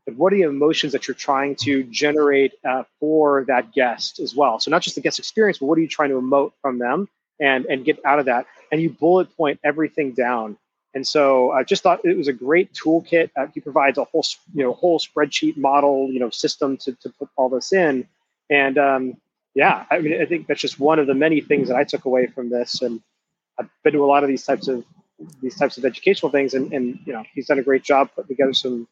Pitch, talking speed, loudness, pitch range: 140 Hz, 245 wpm, -19 LUFS, 130-155 Hz